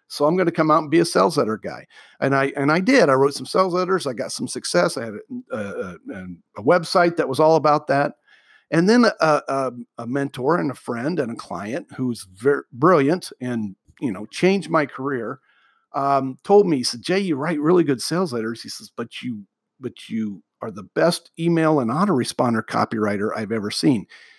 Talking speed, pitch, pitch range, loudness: 210 wpm, 145 Hz, 125-170 Hz, -21 LUFS